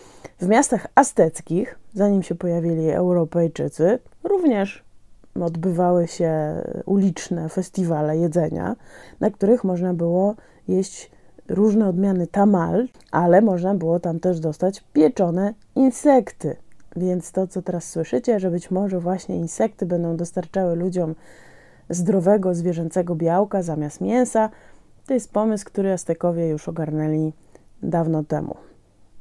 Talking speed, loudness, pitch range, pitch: 115 wpm, -21 LUFS, 165-195 Hz, 180 Hz